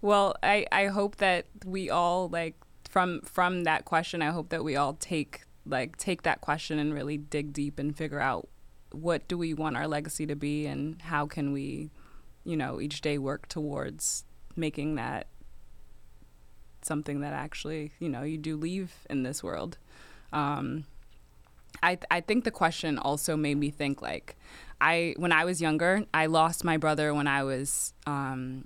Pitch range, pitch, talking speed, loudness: 140-165 Hz, 150 Hz, 175 wpm, -30 LUFS